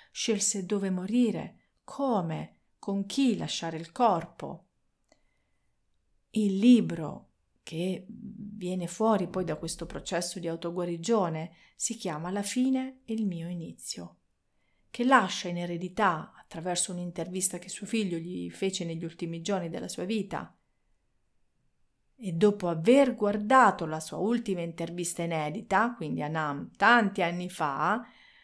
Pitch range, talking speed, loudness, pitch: 170-220 Hz, 125 wpm, -29 LUFS, 185 Hz